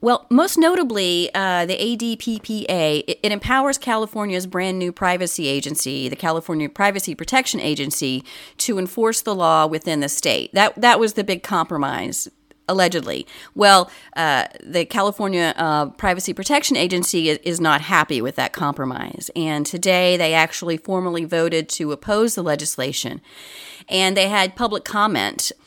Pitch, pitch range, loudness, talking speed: 180 Hz, 160-210 Hz, -19 LUFS, 145 wpm